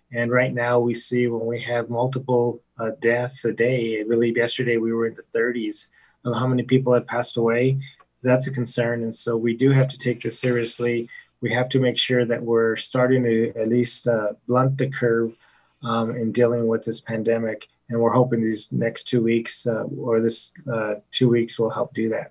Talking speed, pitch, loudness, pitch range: 210 wpm, 120 Hz, -22 LUFS, 115-125 Hz